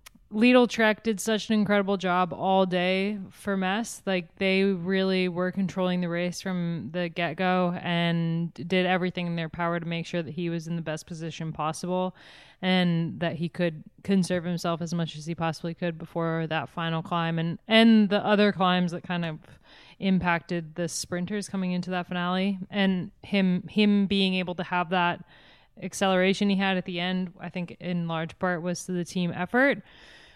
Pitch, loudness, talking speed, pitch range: 180 Hz, -27 LUFS, 185 wpm, 170-190 Hz